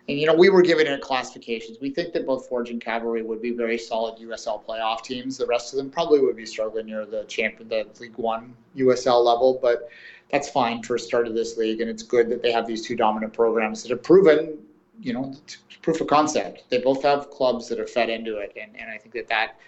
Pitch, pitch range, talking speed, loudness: 120 Hz, 115-135 Hz, 245 wpm, -23 LUFS